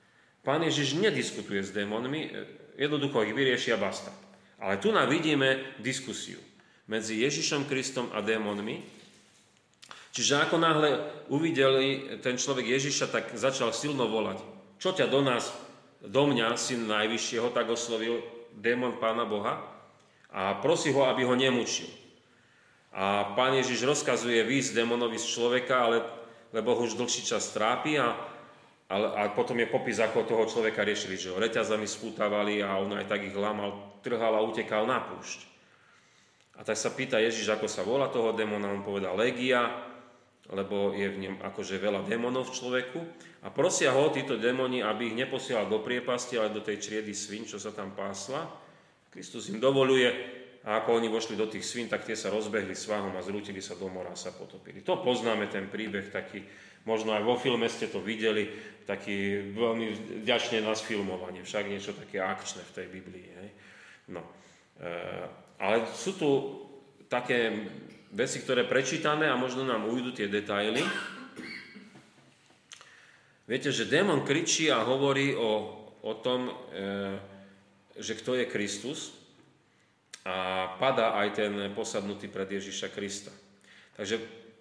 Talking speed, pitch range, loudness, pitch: 155 wpm, 105-125 Hz, -30 LUFS, 115 Hz